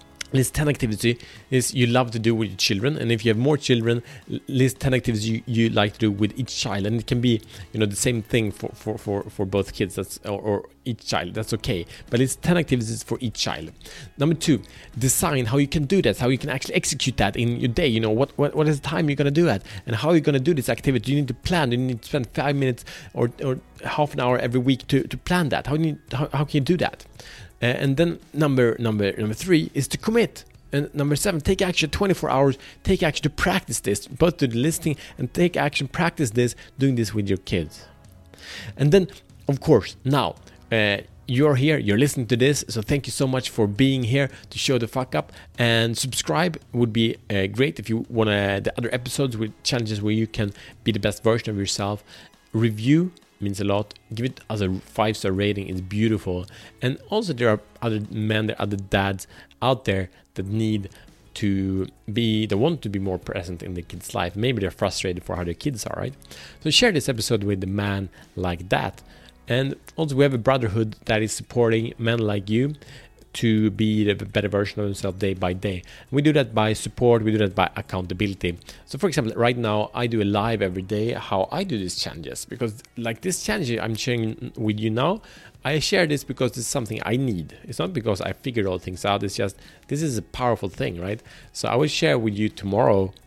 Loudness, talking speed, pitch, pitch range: -23 LUFS, 230 wpm, 115 Hz, 105-135 Hz